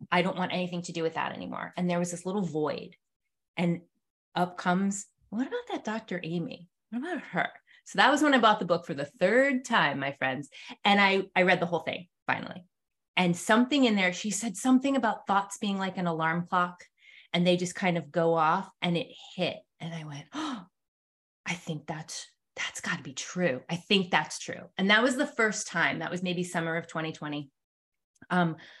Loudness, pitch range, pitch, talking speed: -28 LUFS, 165-210 Hz, 180 Hz, 210 wpm